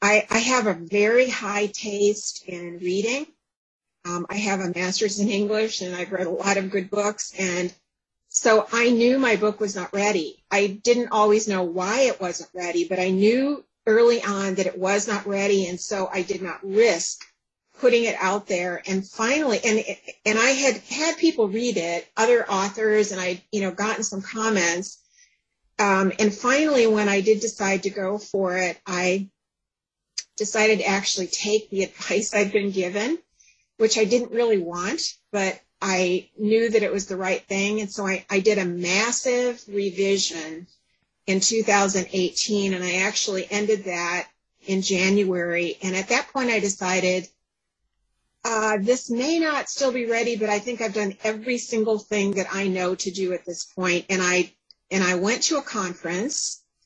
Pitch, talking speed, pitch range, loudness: 205 Hz, 180 wpm, 185-220 Hz, -23 LUFS